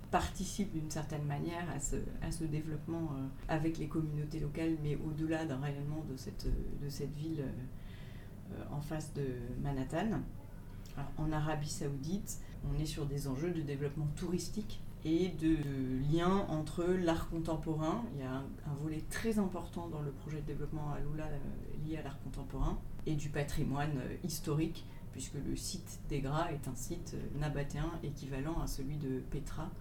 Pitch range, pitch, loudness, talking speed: 140-160 Hz, 150 Hz, -39 LUFS, 175 wpm